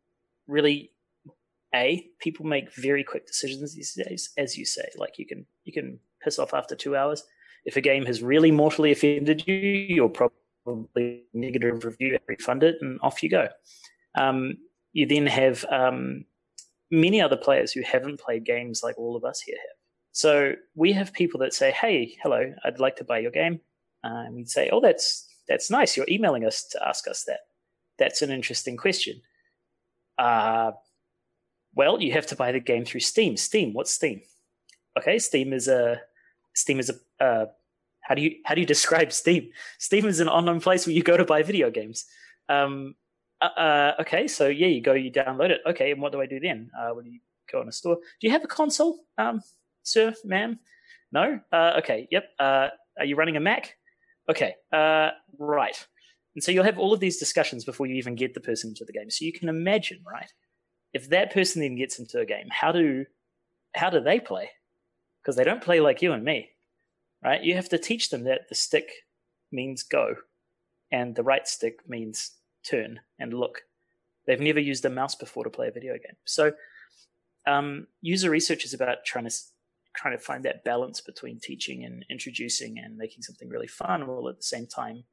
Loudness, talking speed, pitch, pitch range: -25 LUFS, 195 wpm, 155 Hz, 130-195 Hz